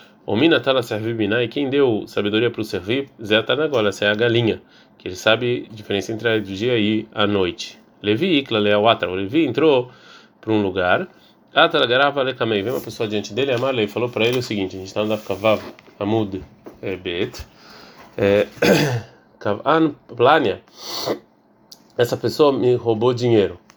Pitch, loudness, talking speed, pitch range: 110 Hz, -20 LUFS, 180 wpm, 105-125 Hz